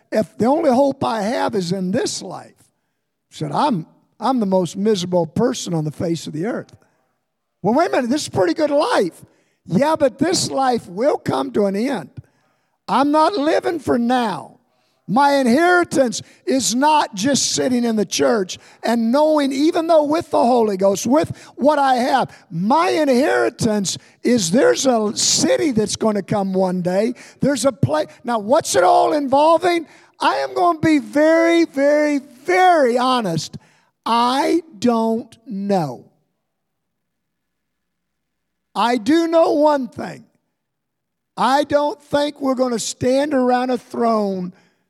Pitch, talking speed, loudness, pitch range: 255 Hz, 150 wpm, -18 LUFS, 210-295 Hz